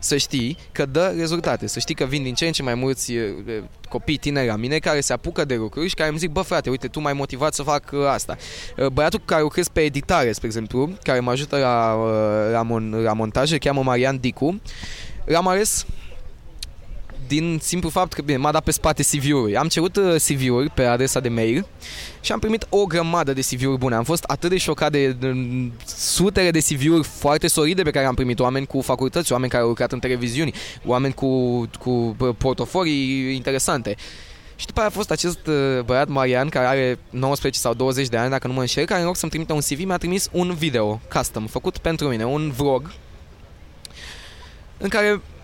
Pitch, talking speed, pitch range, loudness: 135 Hz, 200 wpm, 120-155 Hz, -21 LUFS